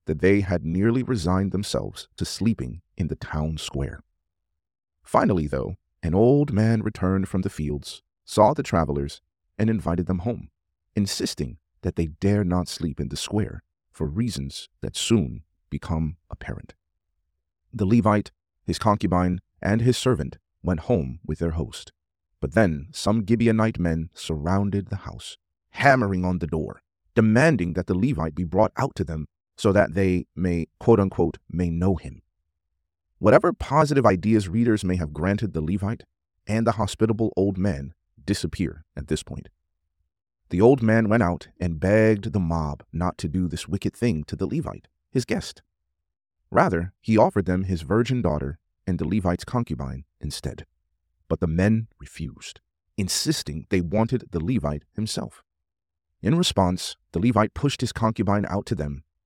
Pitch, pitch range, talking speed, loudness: 90 Hz, 80-105 Hz, 155 wpm, -24 LUFS